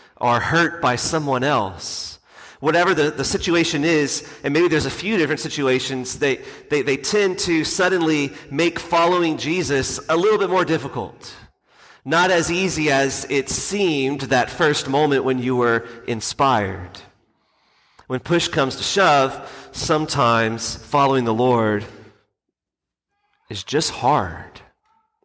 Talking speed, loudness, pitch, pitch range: 135 wpm, -19 LUFS, 145 Hz, 125-170 Hz